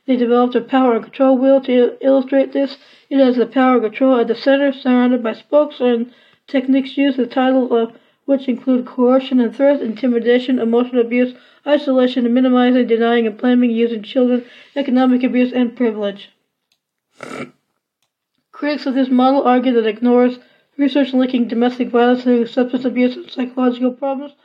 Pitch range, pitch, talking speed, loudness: 245-270 Hz, 250 Hz, 160 wpm, -16 LUFS